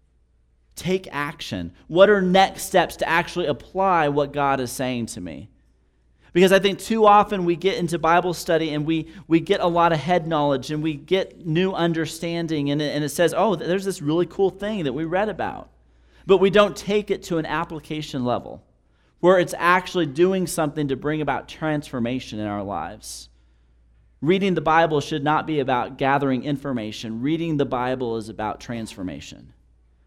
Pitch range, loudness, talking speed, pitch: 125-180 Hz, -22 LUFS, 180 wpm, 155 Hz